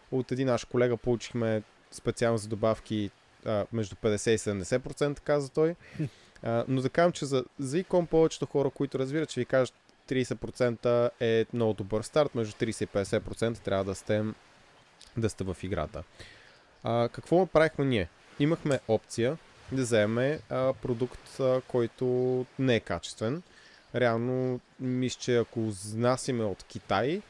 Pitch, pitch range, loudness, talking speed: 120 Hz, 110-130 Hz, -30 LUFS, 145 wpm